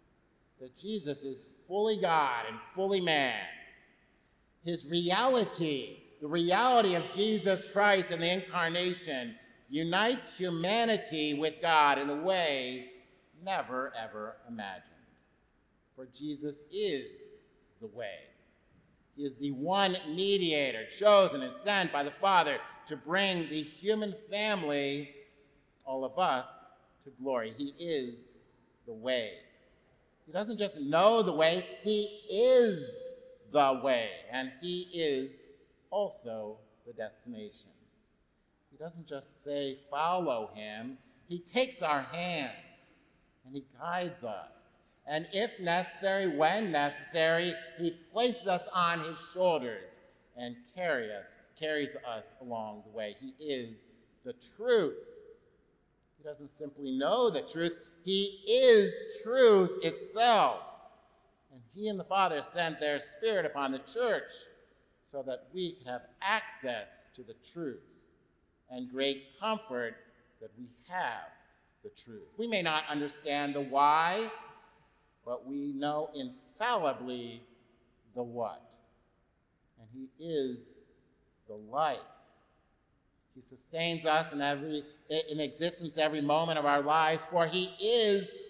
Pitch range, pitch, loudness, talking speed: 140-205 Hz, 165 Hz, -31 LUFS, 125 wpm